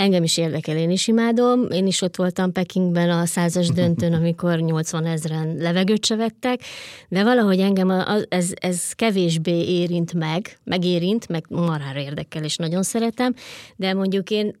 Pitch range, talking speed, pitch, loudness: 170-195 Hz, 160 wpm, 180 Hz, -21 LUFS